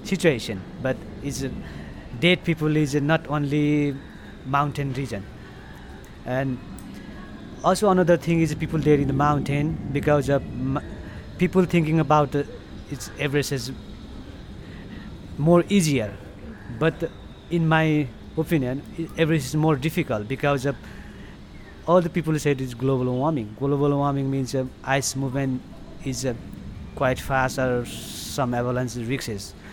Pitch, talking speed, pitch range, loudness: 140 Hz, 135 wpm, 130-160 Hz, -24 LUFS